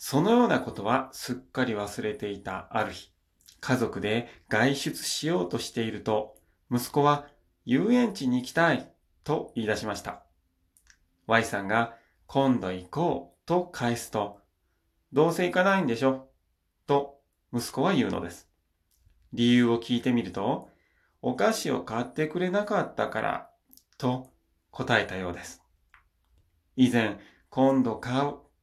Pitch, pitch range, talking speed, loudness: 115 Hz, 90-140 Hz, 260 characters per minute, -28 LUFS